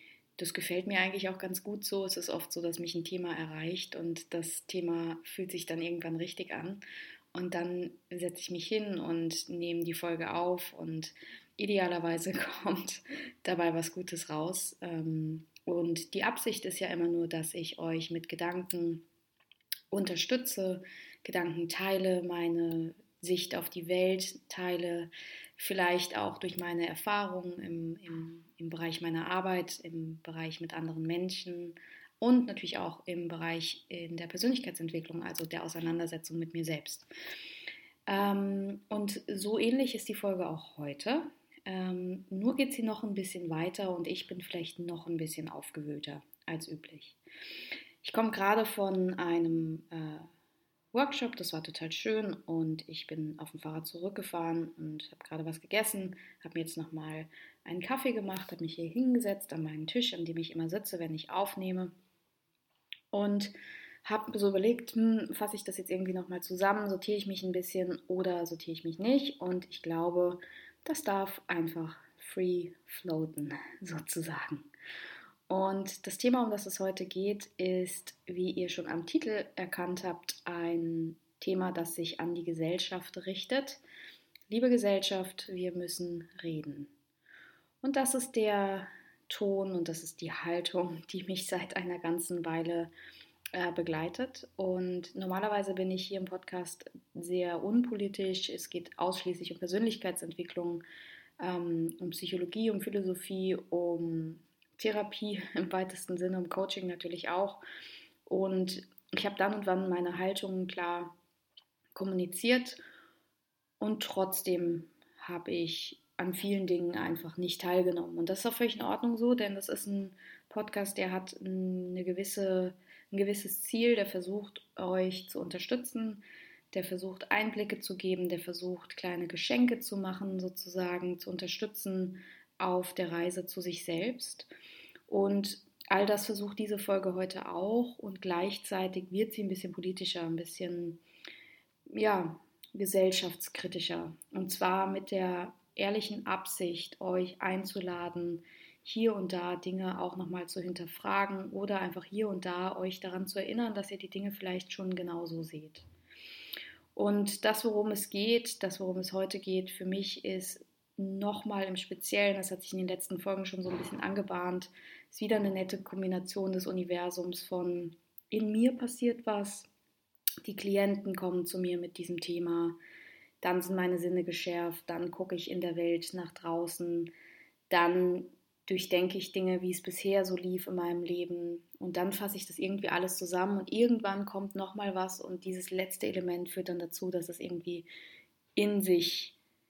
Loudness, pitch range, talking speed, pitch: -35 LUFS, 170-195 Hz, 155 wpm, 185 Hz